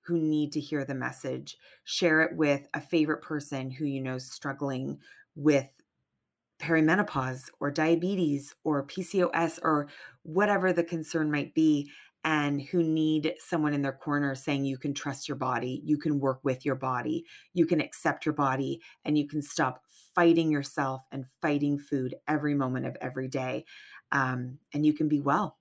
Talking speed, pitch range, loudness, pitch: 170 wpm, 135-160 Hz, -28 LUFS, 150 Hz